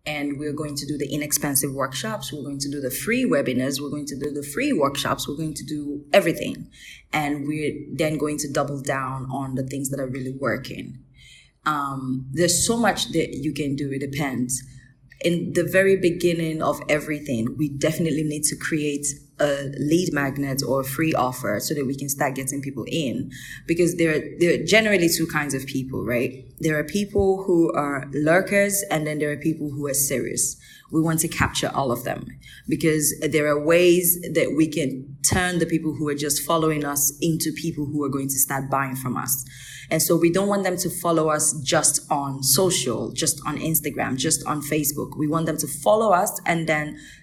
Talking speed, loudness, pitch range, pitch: 205 wpm, -23 LUFS, 140-160 Hz, 150 Hz